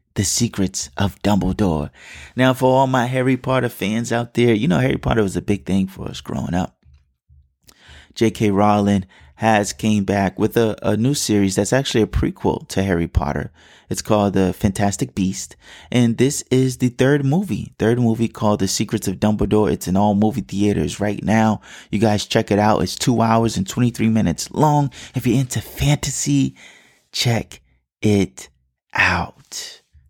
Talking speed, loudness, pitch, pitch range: 170 wpm, -19 LUFS, 105 Hz, 95-120 Hz